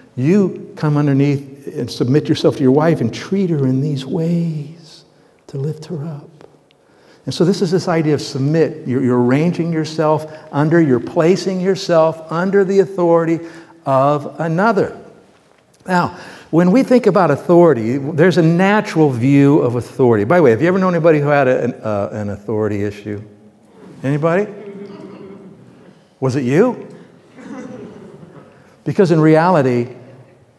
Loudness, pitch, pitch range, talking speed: -15 LUFS, 160 Hz, 140-185 Hz, 145 wpm